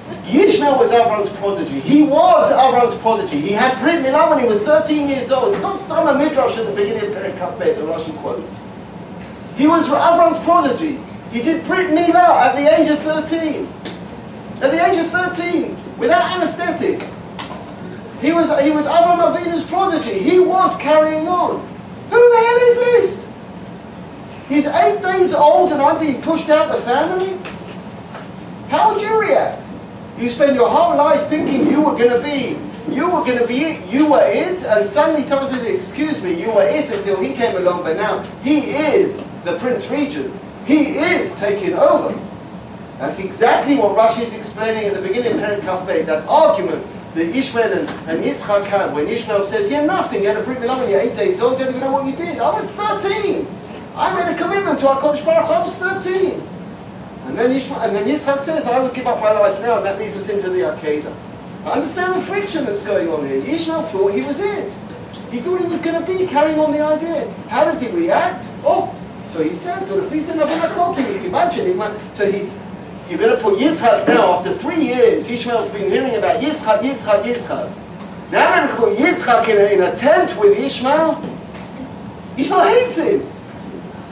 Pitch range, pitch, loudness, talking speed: 235-340 Hz, 300 Hz, -16 LUFS, 190 wpm